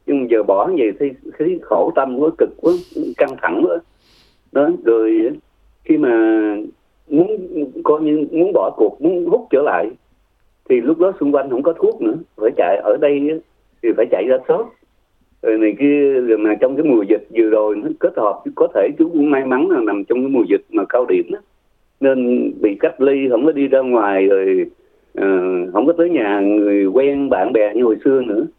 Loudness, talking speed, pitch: -16 LUFS, 210 wpm, 325 Hz